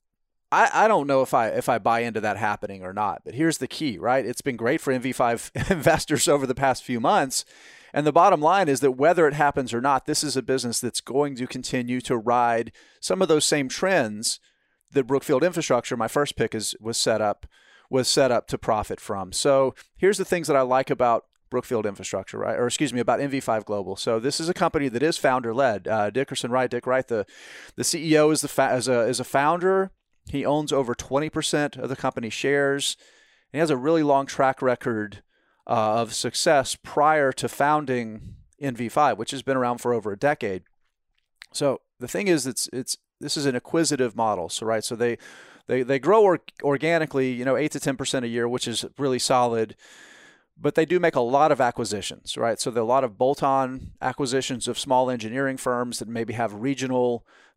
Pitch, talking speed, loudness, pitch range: 130 Hz, 210 wpm, -24 LUFS, 120-145 Hz